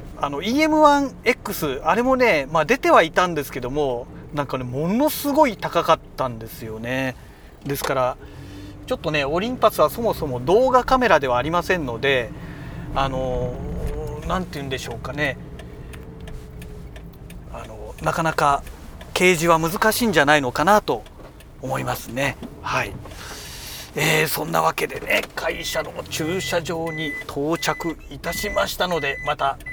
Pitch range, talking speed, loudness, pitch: 135-200 Hz, 295 characters per minute, -21 LUFS, 155 Hz